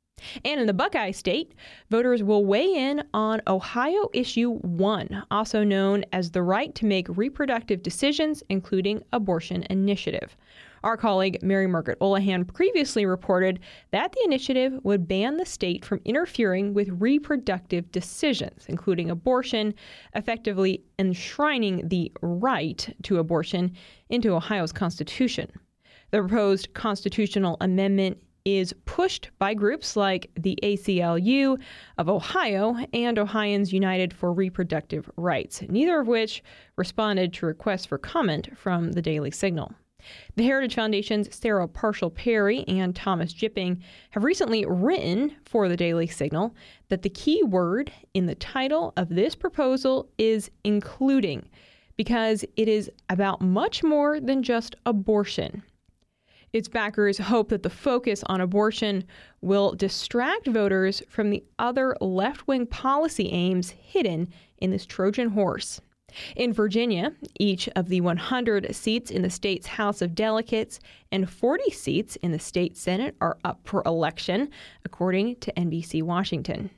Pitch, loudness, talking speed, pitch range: 205 Hz, -25 LUFS, 135 wpm, 185-235 Hz